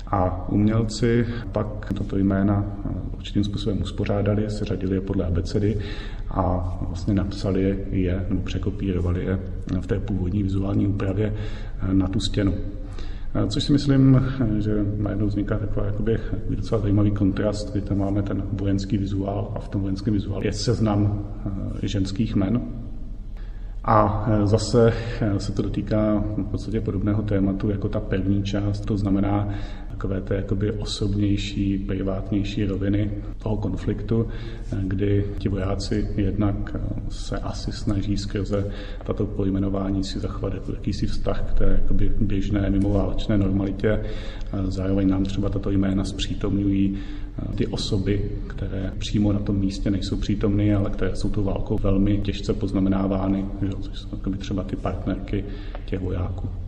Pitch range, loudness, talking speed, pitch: 95-105 Hz, -25 LUFS, 130 wpm, 100 Hz